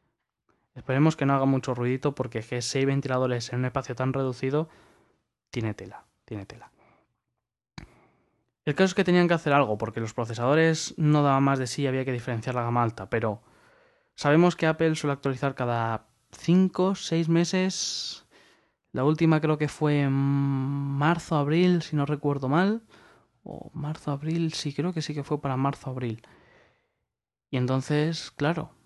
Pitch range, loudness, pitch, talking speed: 130-160 Hz, -26 LUFS, 140 Hz, 160 wpm